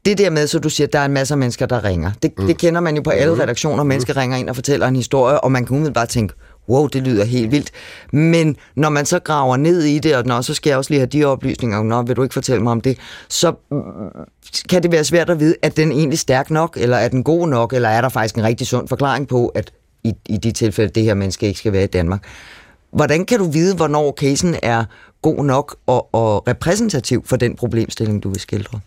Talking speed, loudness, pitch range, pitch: 260 wpm, -17 LUFS, 115-150 Hz, 130 Hz